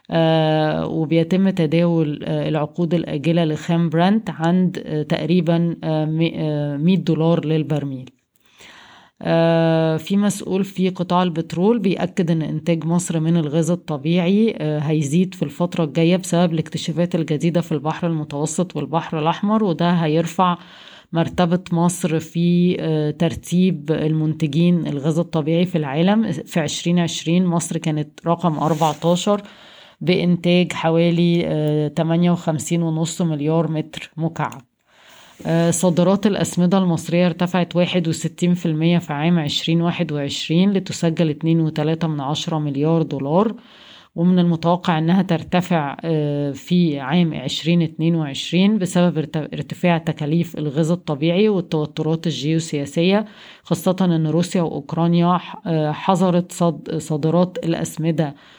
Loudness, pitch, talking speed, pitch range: -19 LUFS, 165 Hz, 100 wpm, 155-175 Hz